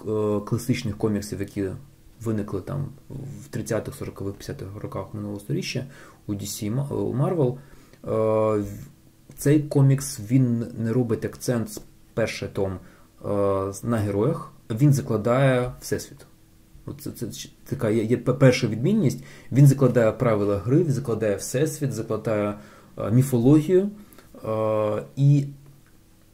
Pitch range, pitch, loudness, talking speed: 105-135 Hz, 115 Hz, -24 LUFS, 105 wpm